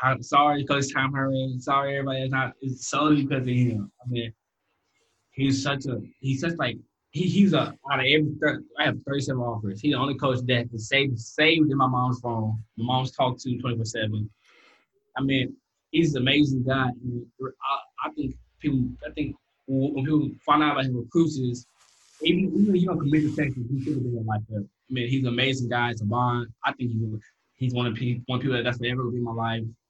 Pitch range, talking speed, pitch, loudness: 120-140 Hz, 220 wpm, 130 Hz, -25 LUFS